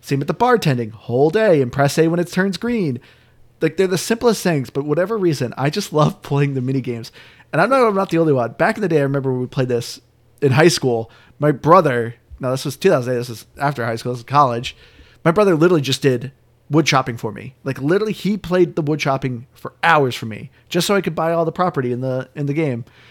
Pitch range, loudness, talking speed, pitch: 125-170 Hz, -18 LUFS, 250 wpm, 140 Hz